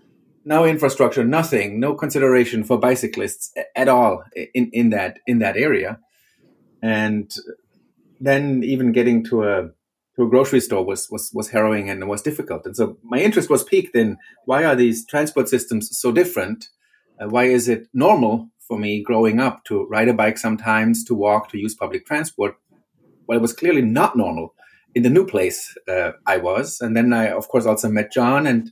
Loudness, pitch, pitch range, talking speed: -19 LUFS, 120 Hz, 110-135 Hz, 185 wpm